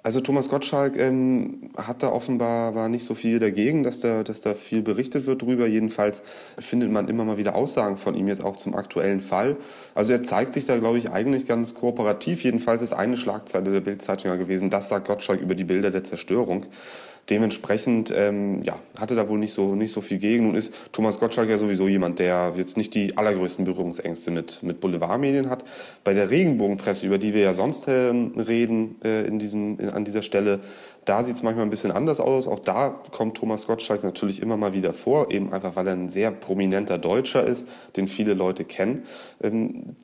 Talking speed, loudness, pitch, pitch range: 205 wpm, -24 LUFS, 105 Hz, 100-115 Hz